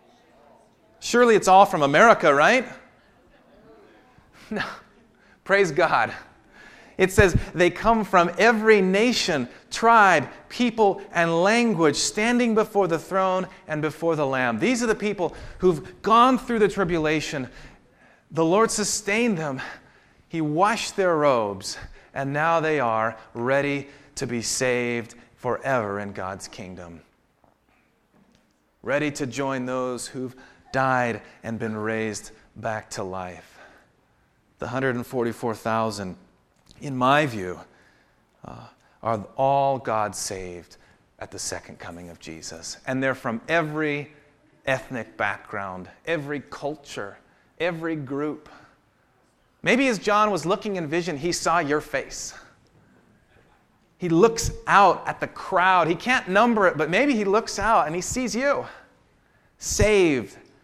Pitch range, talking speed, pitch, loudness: 120-195 Hz, 125 wpm, 150 Hz, -22 LUFS